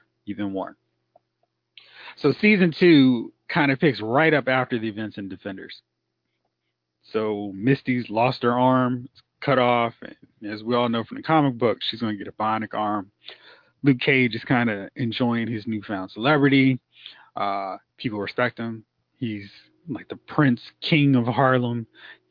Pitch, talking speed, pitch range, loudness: 120 Hz, 160 wpm, 105-135 Hz, -22 LUFS